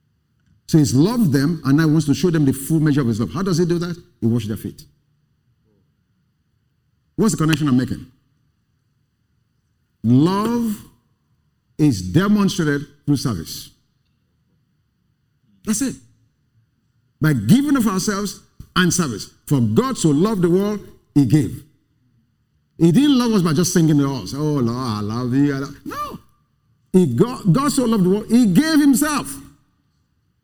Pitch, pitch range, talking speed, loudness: 150 Hz, 130-190 Hz, 150 wpm, -18 LUFS